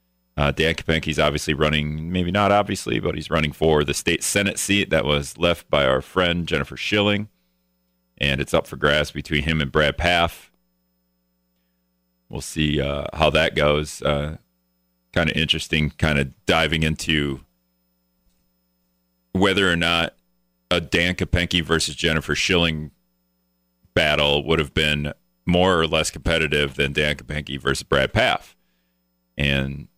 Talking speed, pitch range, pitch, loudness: 145 wpm, 60-85 Hz, 75 Hz, -21 LUFS